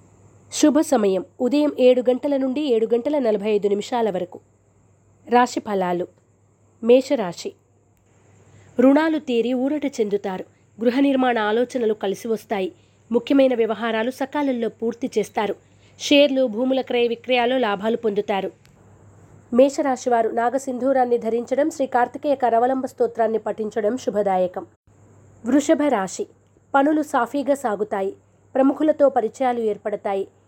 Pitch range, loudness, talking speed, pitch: 200-265 Hz, -21 LUFS, 100 wpm, 235 Hz